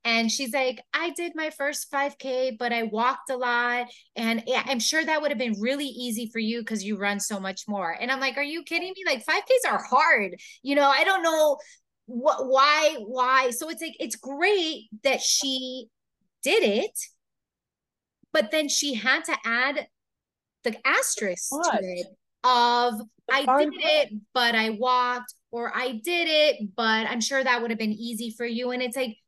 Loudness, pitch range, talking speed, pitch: -25 LUFS, 230-290 Hz, 190 wpm, 255 Hz